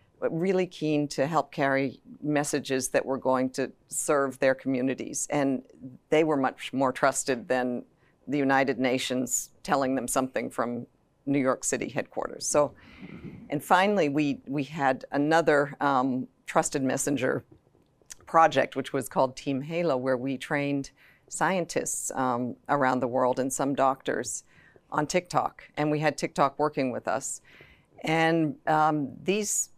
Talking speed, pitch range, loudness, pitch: 140 wpm, 130-150 Hz, -27 LUFS, 140 Hz